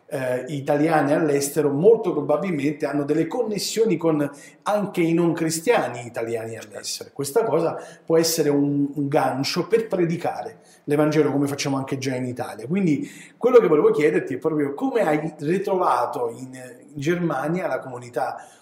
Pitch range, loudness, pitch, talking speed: 140-165 Hz, -22 LUFS, 155 Hz, 150 wpm